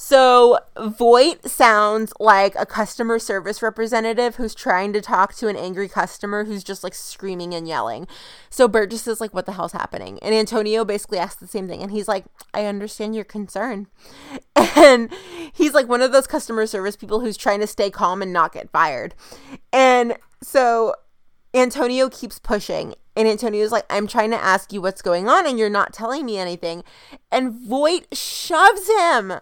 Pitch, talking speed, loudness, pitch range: 220 Hz, 180 wpm, -19 LUFS, 200-245 Hz